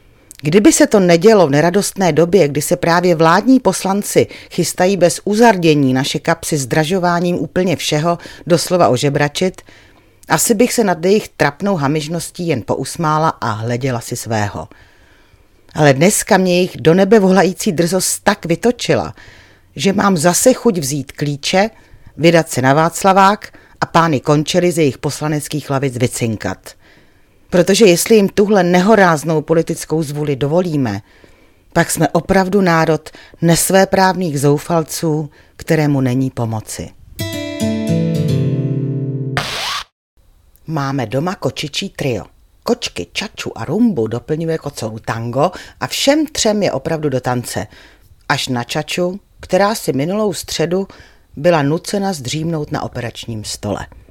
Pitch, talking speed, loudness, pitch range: 160 Hz, 125 wpm, -15 LUFS, 130-180 Hz